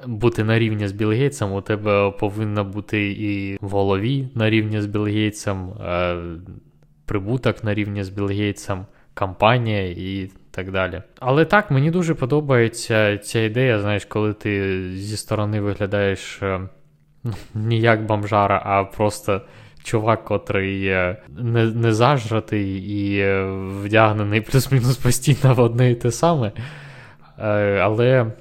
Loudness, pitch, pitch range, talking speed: -20 LUFS, 105 Hz, 100-120 Hz, 125 wpm